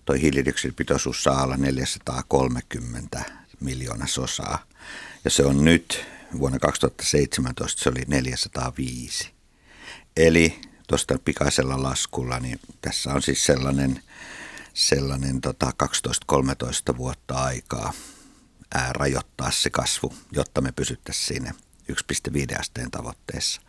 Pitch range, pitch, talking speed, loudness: 65-70 Hz, 65 Hz, 100 wpm, -24 LUFS